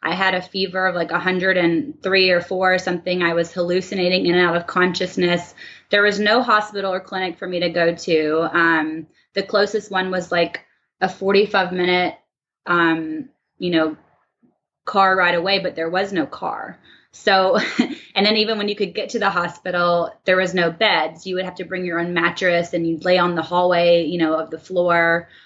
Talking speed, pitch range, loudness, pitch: 195 wpm, 170-190 Hz, -19 LUFS, 180 Hz